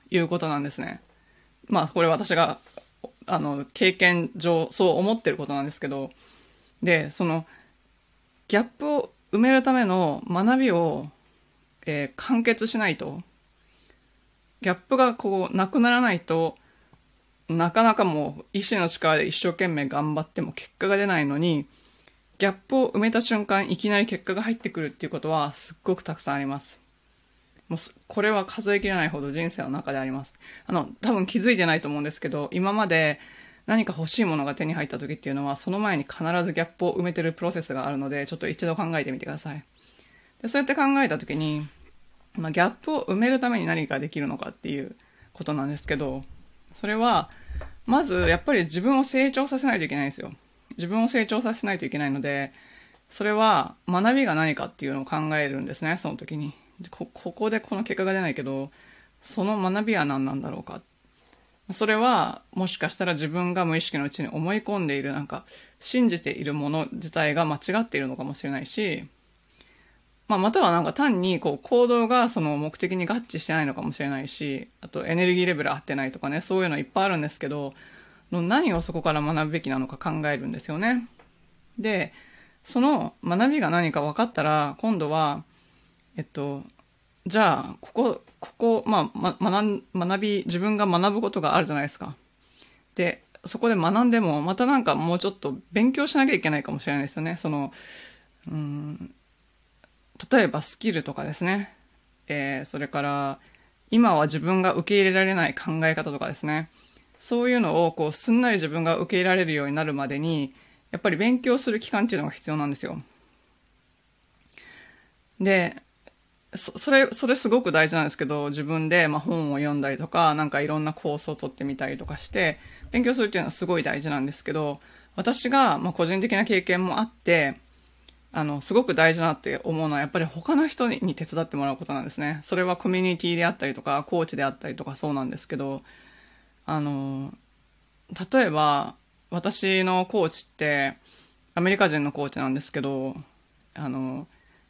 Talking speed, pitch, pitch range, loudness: 370 characters per minute, 170 Hz, 145-210 Hz, -25 LUFS